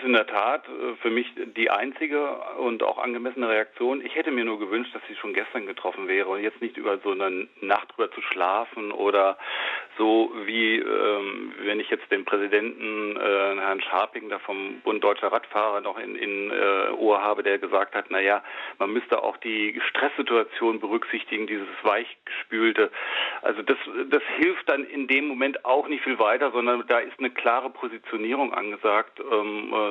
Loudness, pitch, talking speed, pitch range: -25 LUFS, 115 Hz, 175 wpm, 105-145 Hz